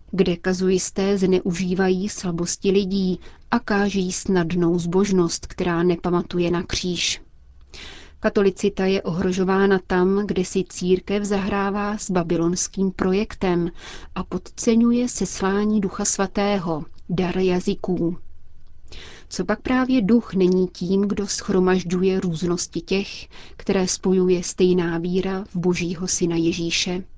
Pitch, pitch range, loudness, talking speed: 185 Hz, 180-200 Hz, -22 LUFS, 110 wpm